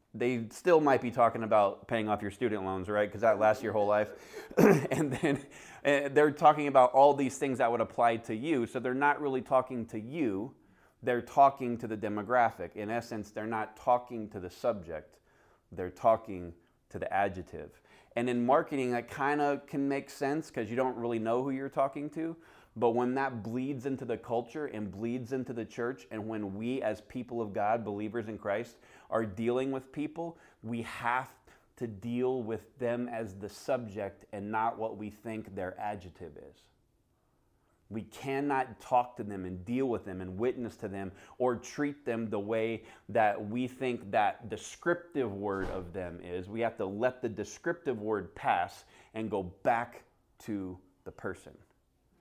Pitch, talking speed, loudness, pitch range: 115 Hz, 180 wpm, -32 LUFS, 105-130 Hz